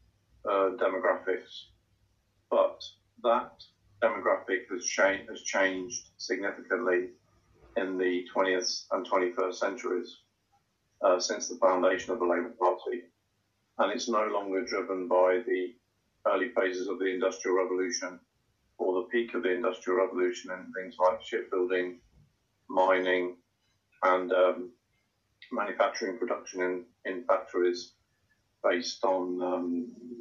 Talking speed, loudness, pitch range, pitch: 115 wpm, -30 LUFS, 90-100 Hz, 95 Hz